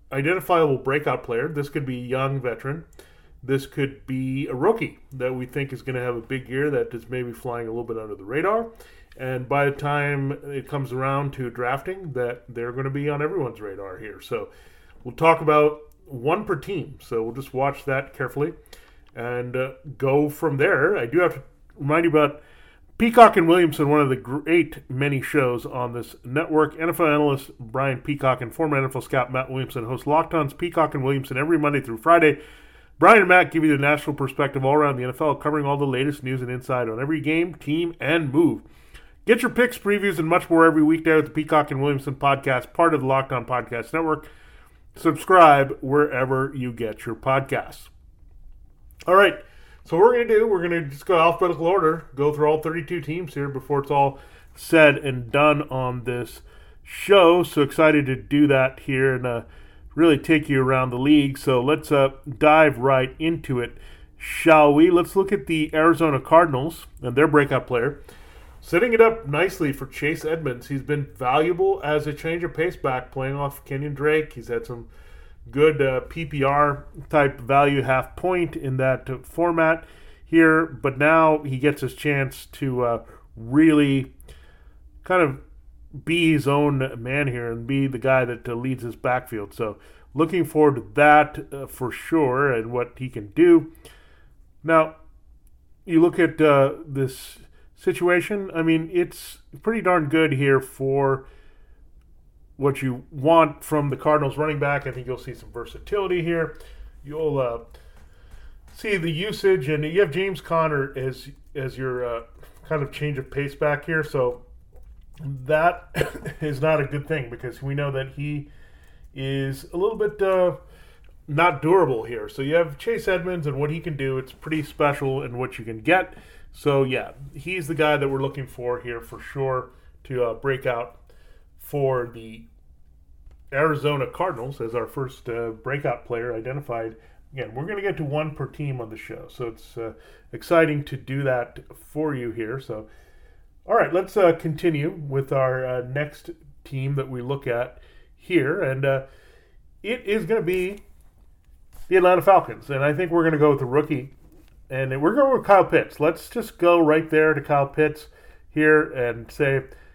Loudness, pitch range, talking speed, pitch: -22 LUFS, 125-160 Hz, 180 wpm, 140 Hz